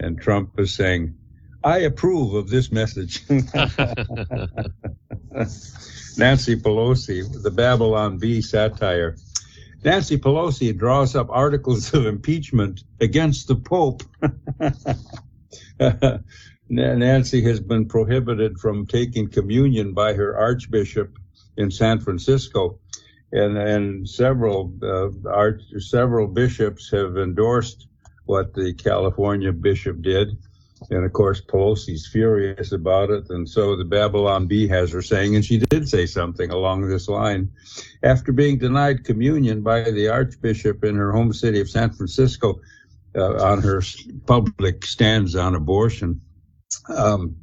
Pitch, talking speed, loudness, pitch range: 110 Hz, 125 wpm, -20 LUFS, 100-120 Hz